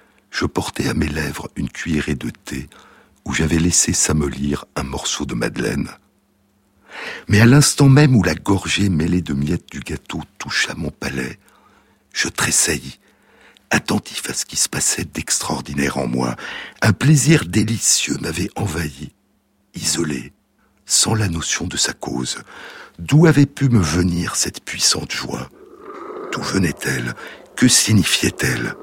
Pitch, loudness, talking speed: 90 Hz, -18 LUFS, 140 wpm